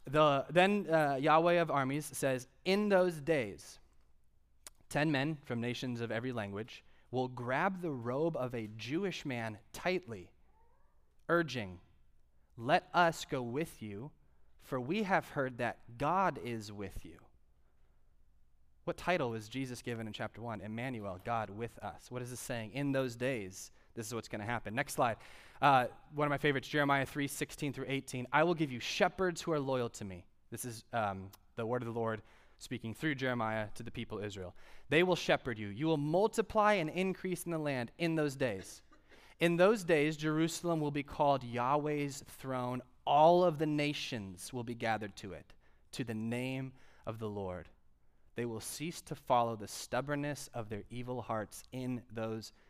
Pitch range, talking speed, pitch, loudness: 110-150 Hz, 180 wpm, 125 Hz, -35 LUFS